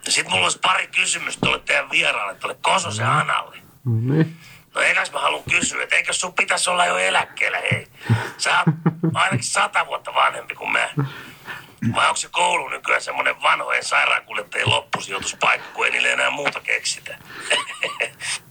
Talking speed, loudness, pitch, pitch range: 160 wpm, -20 LUFS, 160 Hz, 140-175 Hz